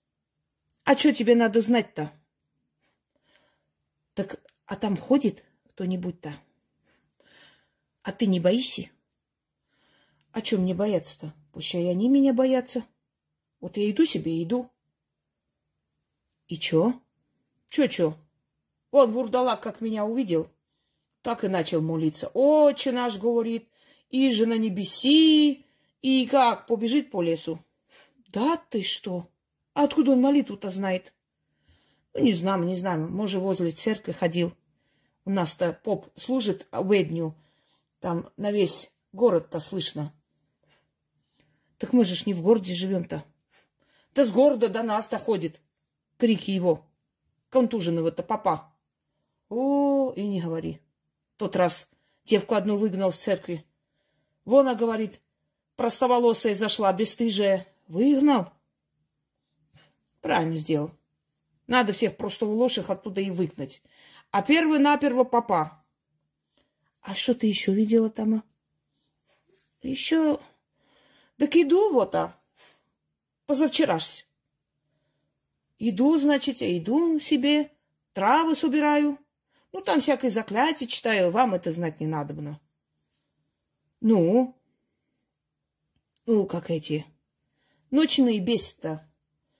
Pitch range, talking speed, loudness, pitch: 170-255 Hz, 115 wpm, -25 LUFS, 210 Hz